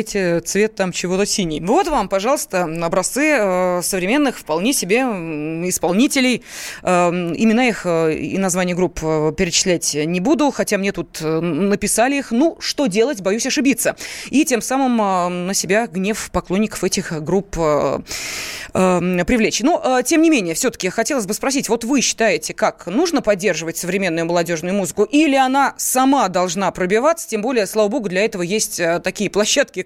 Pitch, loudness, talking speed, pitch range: 205 Hz, -18 LUFS, 145 wpm, 180-250 Hz